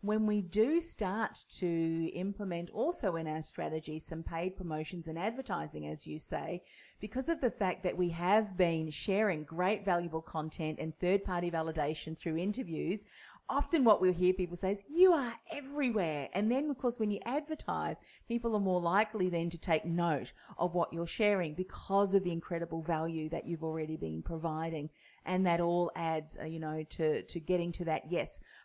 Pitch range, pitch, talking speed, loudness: 160-205 Hz, 175 Hz, 180 wpm, -34 LUFS